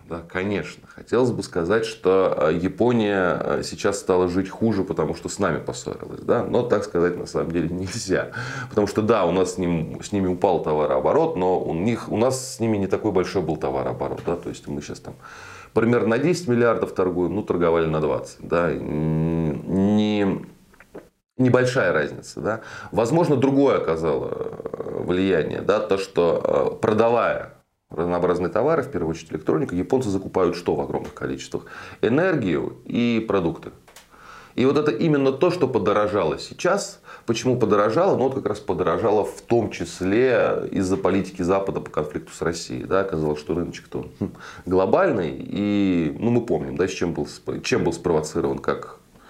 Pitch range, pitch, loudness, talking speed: 90-120 Hz, 100 Hz, -22 LUFS, 160 wpm